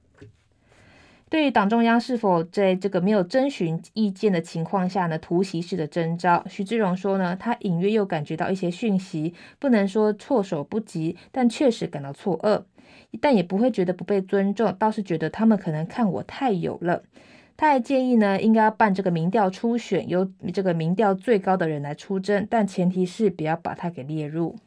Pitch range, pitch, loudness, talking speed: 175-220 Hz, 195 Hz, -23 LUFS, 285 characters per minute